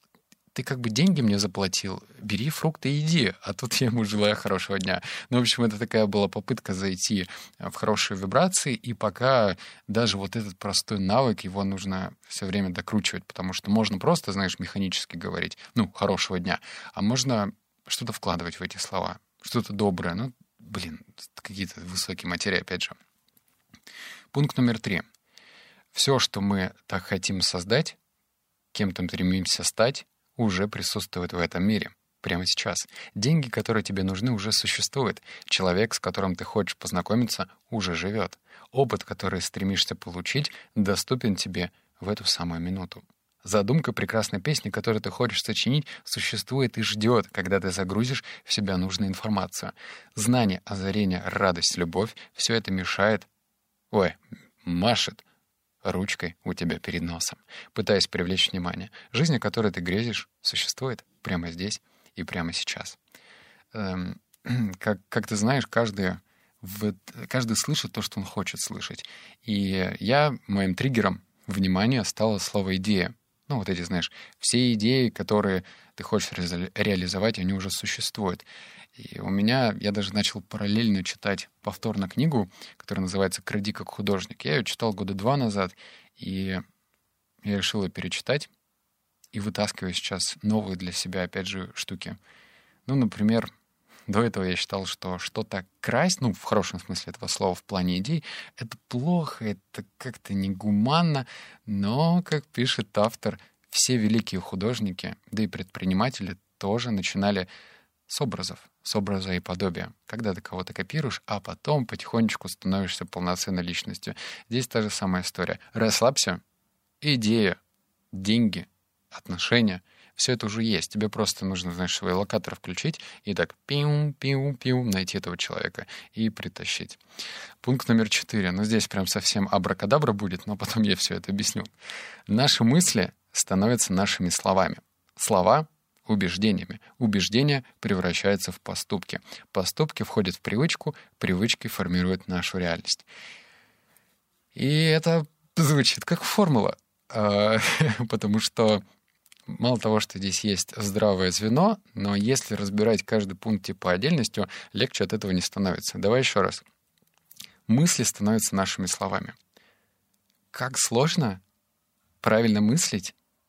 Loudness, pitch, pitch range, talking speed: -26 LUFS, 105 Hz, 95-115 Hz, 140 wpm